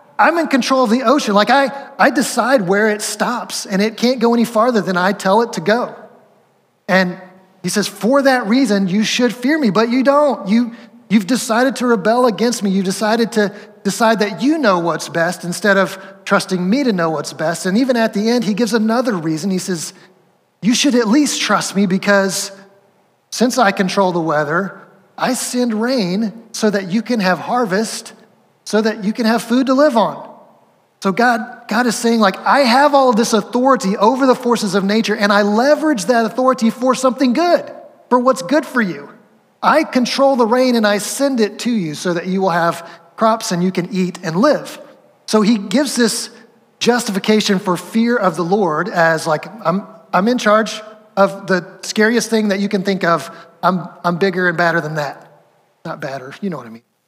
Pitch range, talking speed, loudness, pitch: 190-245 Hz, 205 wpm, -15 LUFS, 215 Hz